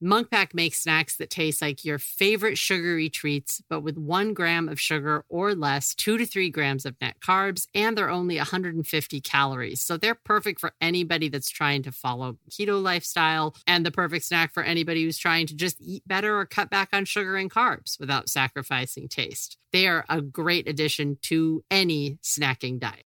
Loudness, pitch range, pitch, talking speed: -25 LUFS, 145-185 Hz, 165 Hz, 185 wpm